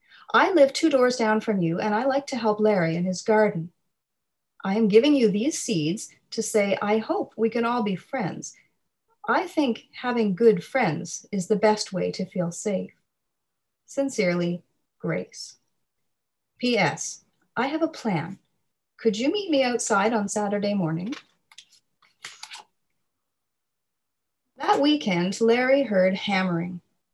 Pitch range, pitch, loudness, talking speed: 190-250 Hz, 215 Hz, -24 LUFS, 140 wpm